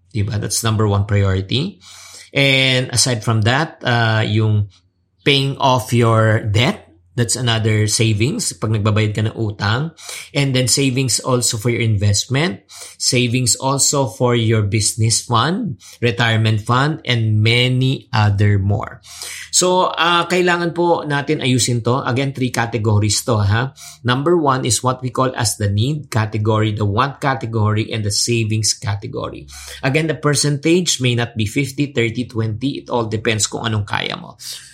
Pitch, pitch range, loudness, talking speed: 120 Hz, 110-135 Hz, -17 LUFS, 150 wpm